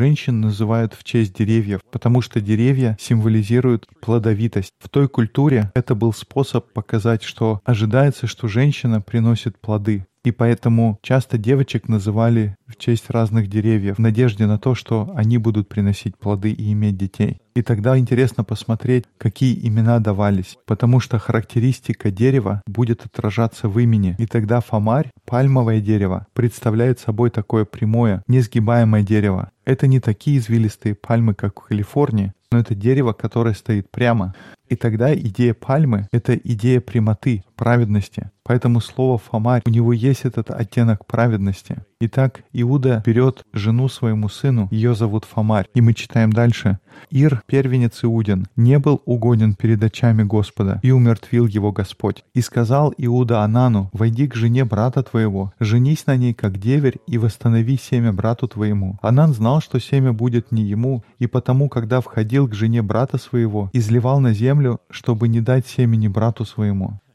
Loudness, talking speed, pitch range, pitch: -18 LUFS, 150 wpm, 110-125 Hz, 115 Hz